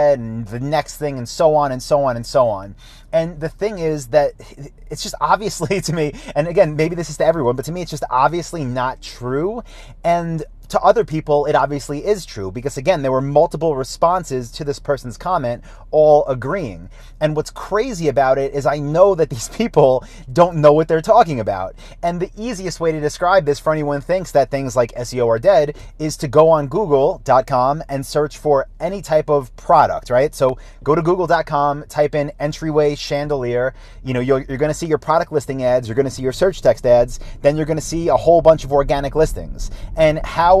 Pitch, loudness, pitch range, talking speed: 145 Hz, -17 LUFS, 130-160 Hz, 215 wpm